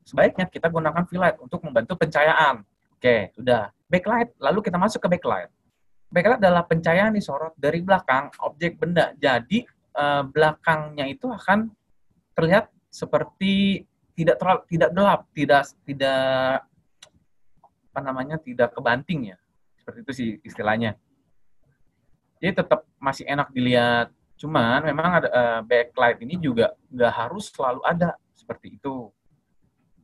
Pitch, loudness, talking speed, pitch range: 155 Hz, -22 LUFS, 130 wpm, 130-180 Hz